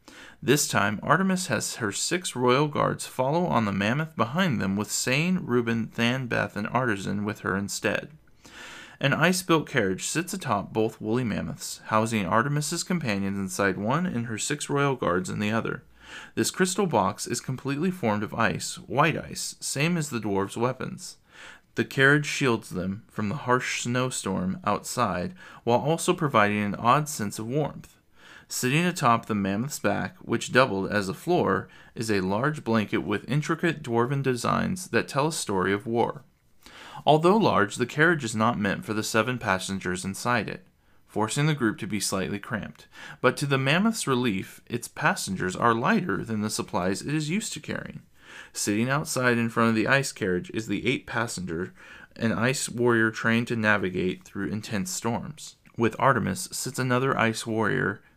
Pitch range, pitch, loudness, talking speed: 105-145 Hz, 115 Hz, -26 LUFS, 170 wpm